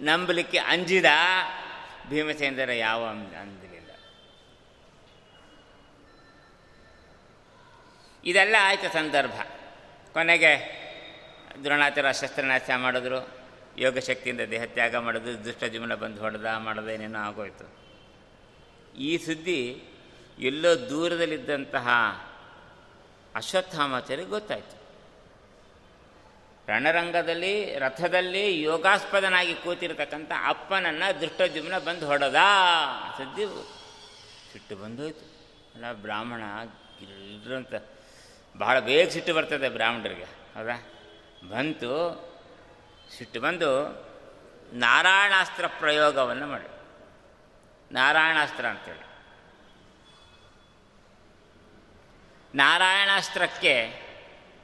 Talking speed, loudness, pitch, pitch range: 65 wpm, -25 LUFS, 150 Hz, 125-170 Hz